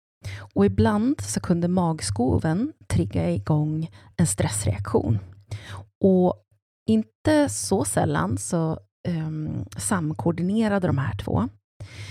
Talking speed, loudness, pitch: 95 wpm, -24 LUFS, 150 Hz